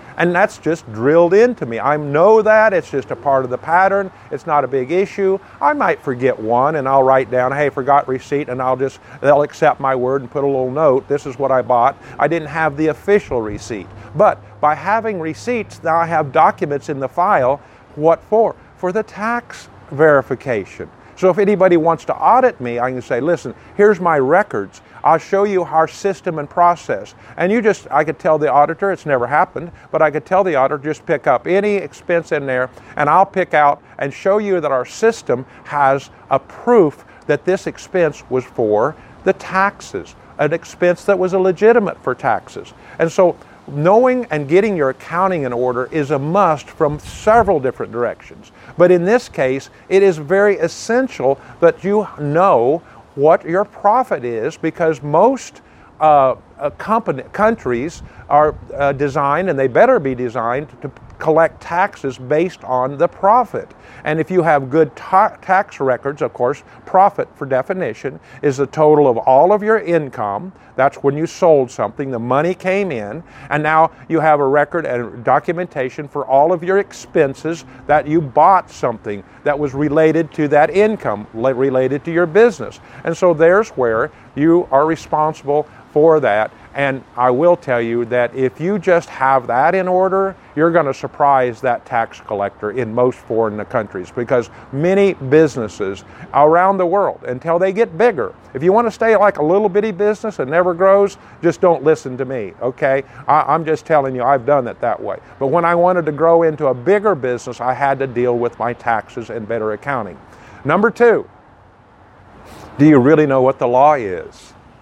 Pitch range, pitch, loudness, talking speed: 130-185 Hz, 150 Hz, -16 LUFS, 185 wpm